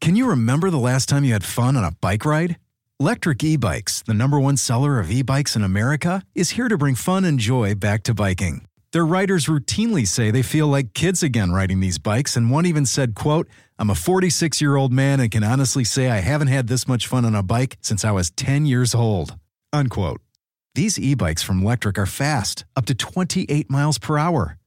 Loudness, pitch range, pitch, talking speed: -20 LUFS, 110-150 Hz, 130 Hz, 210 wpm